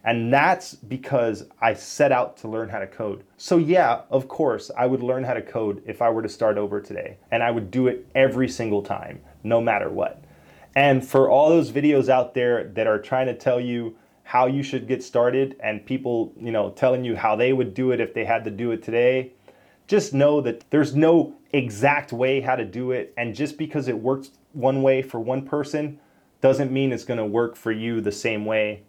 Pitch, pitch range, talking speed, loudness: 125 Hz, 115-135 Hz, 220 wpm, -22 LUFS